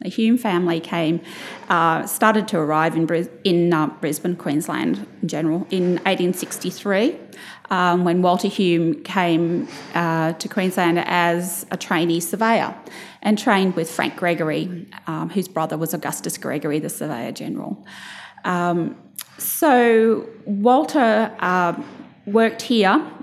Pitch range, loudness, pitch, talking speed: 165-205 Hz, -20 LUFS, 180 Hz, 130 wpm